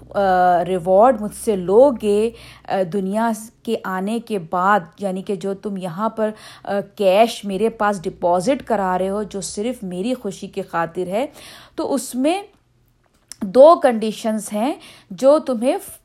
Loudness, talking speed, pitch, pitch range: -19 LUFS, 155 wpm, 210 Hz, 190-230 Hz